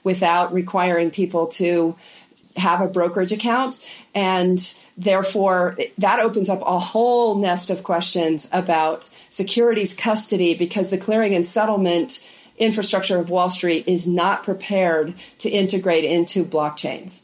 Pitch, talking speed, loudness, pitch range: 185 Hz, 130 wpm, -20 LUFS, 170-200 Hz